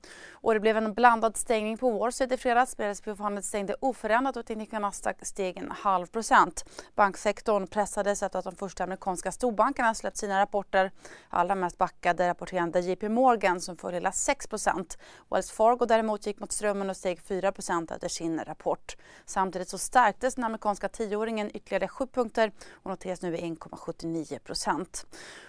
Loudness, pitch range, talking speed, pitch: -28 LUFS, 185-225 Hz, 150 wpm, 205 Hz